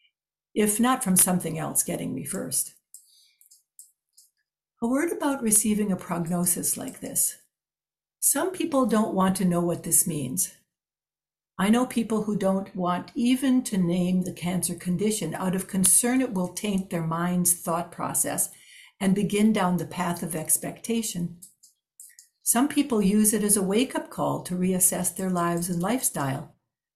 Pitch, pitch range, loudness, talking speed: 190 Hz, 175-230 Hz, -24 LUFS, 155 wpm